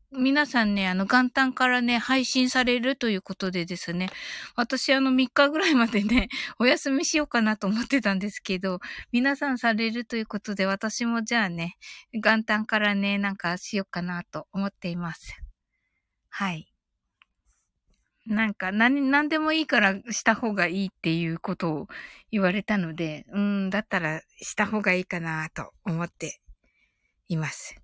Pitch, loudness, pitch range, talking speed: 210 Hz, -25 LUFS, 185-245 Hz, 310 characters per minute